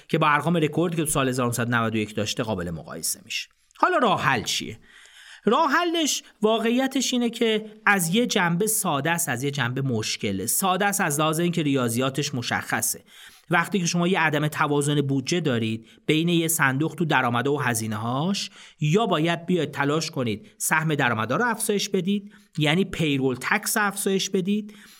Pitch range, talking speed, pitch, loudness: 135-205 Hz, 165 wpm, 160 Hz, -23 LUFS